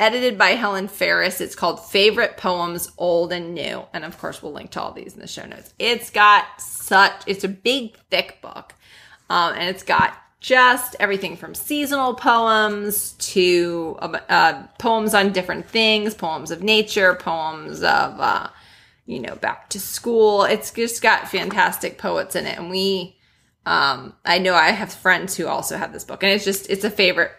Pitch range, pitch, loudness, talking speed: 180-225 Hz, 200 Hz, -19 LUFS, 180 wpm